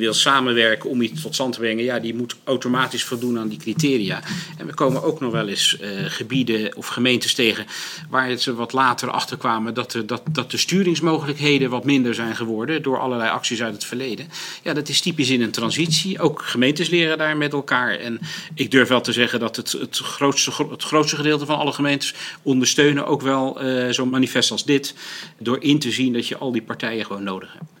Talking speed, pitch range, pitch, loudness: 215 wpm, 120-150 Hz, 130 Hz, -20 LUFS